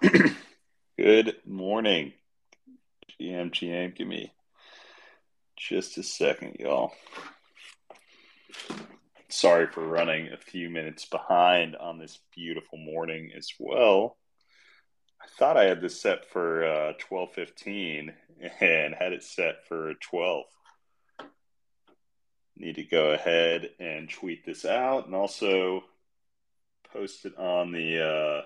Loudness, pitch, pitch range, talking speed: -27 LUFS, 85 Hz, 80-90 Hz, 115 wpm